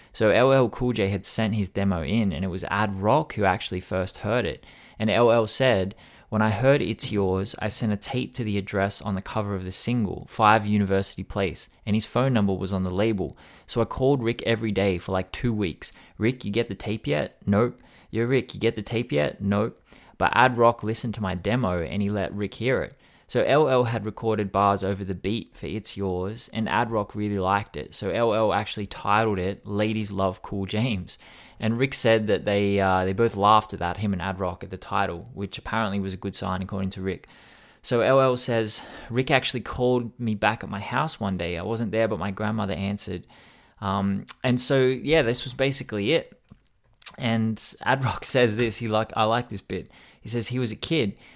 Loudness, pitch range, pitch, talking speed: -25 LUFS, 95-115 Hz, 105 Hz, 220 wpm